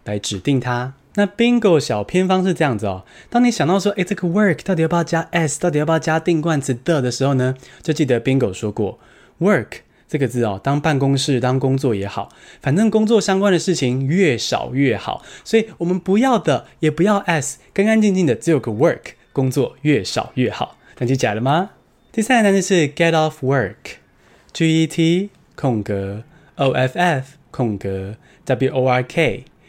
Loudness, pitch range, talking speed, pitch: -18 LUFS, 130-185 Hz, 315 characters per minute, 155 Hz